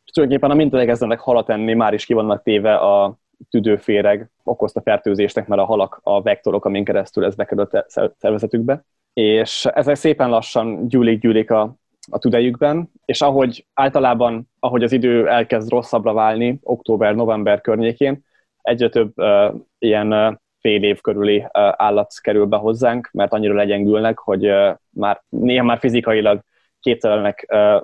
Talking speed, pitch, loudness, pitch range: 150 wpm, 115 Hz, -17 LUFS, 105-125 Hz